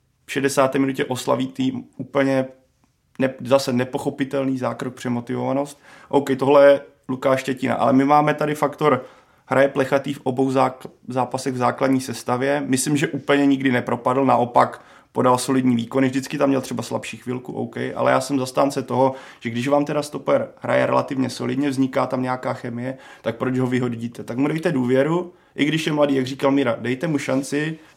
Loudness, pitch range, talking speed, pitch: -21 LUFS, 125-140 Hz, 170 wpm, 135 Hz